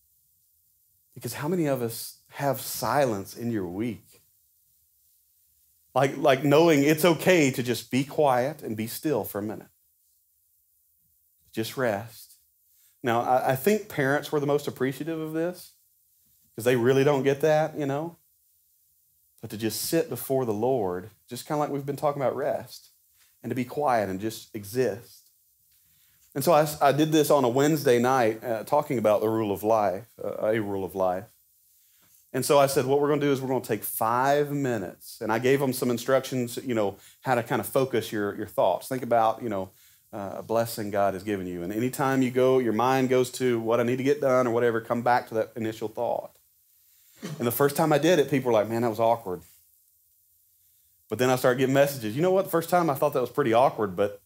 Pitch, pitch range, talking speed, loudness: 120 Hz, 95-140 Hz, 210 wpm, -25 LUFS